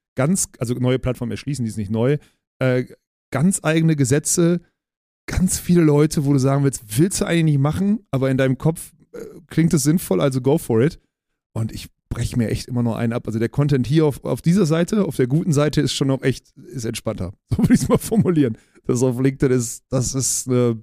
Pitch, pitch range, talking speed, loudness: 135 Hz, 125-160 Hz, 220 wpm, -20 LUFS